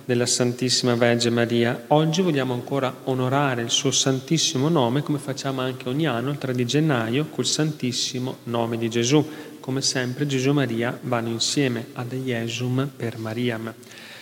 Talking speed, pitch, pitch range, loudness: 155 wpm, 130 Hz, 120-140 Hz, -23 LUFS